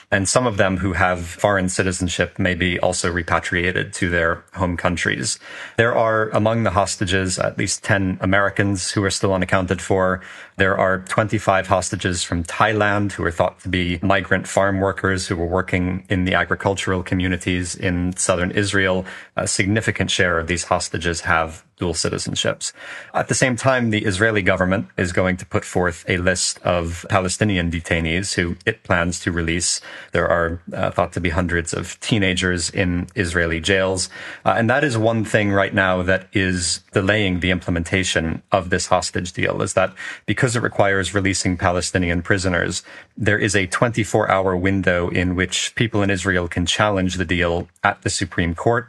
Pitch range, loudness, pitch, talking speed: 90-100 Hz, -20 LUFS, 95 Hz, 175 wpm